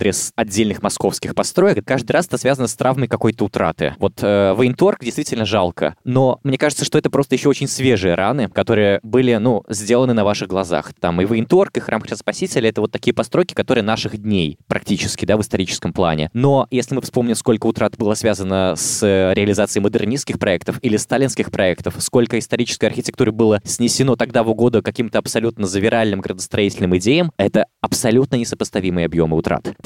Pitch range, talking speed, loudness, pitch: 100-125 Hz, 170 wpm, -17 LUFS, 115 Hz